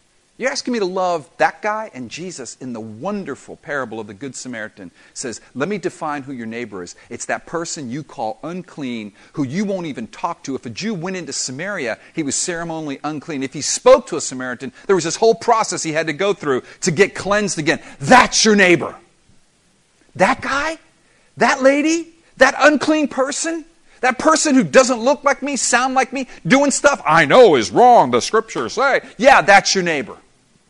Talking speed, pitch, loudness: 195 wpm, 190 Hz, -17 LUFS